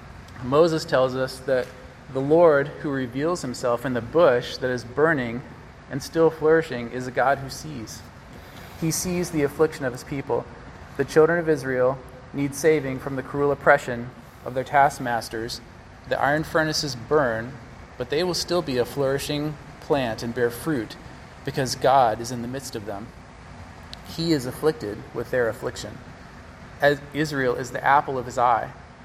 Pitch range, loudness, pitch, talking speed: 125-150 Hz, -23 LUFS, 135 Hz, 165 wpm